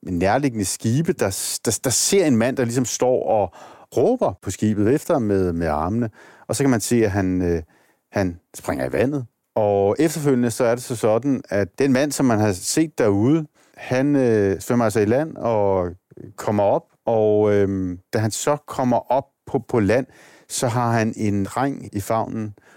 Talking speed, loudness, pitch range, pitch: 195 wpm, -21 LUFS, 100-130 Hz, 110 Hz